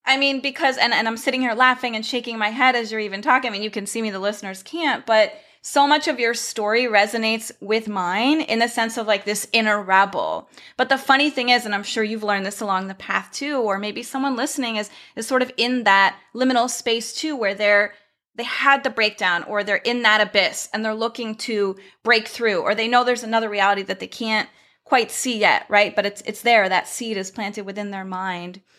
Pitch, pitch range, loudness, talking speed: 225 Hz, 205-255 Hz, -20 LUFS, 235 wpm